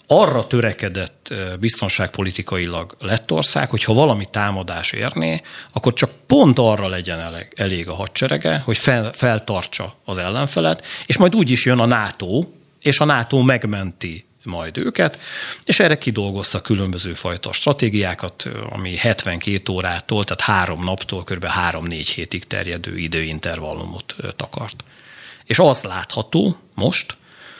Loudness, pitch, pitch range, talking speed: -18 LUFS, 100 Hz, 90-115 Hz, 125 wpm